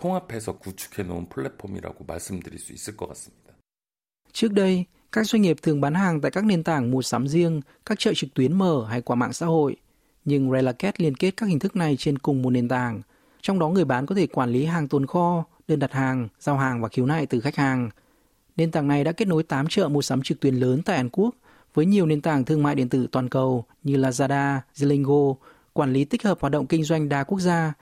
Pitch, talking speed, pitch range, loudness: 145 Hz, 215 wpm, 130-170 Hz, -23 LUFS